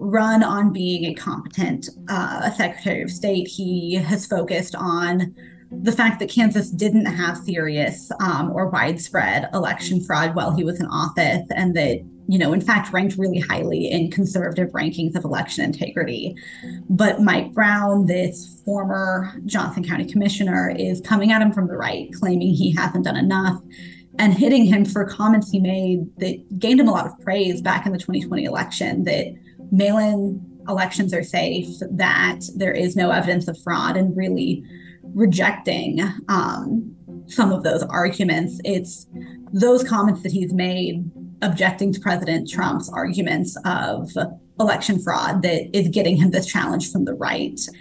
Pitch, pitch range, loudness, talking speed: 185 Hz, 170-200 Hz, -20 LUFS, 160 wpm